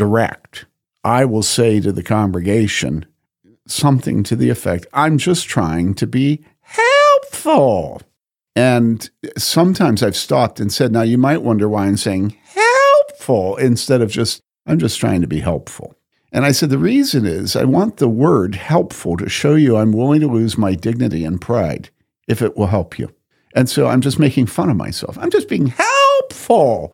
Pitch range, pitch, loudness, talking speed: 105-150 Hz, 120 Hz, -15 LUFS, 175 wpm